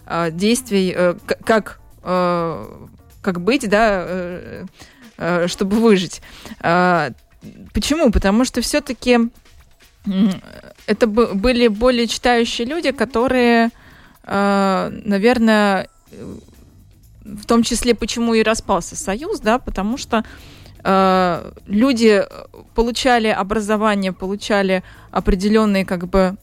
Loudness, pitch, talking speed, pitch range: -17 LUFS, 215 Hz, 80 wpm, 190-235 Hz